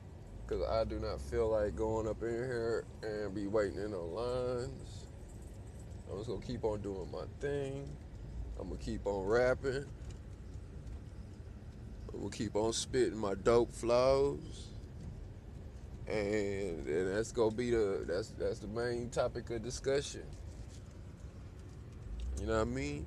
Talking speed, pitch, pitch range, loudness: 145 wpm, 110 Hz, 100-120 Hz, -36 LUFS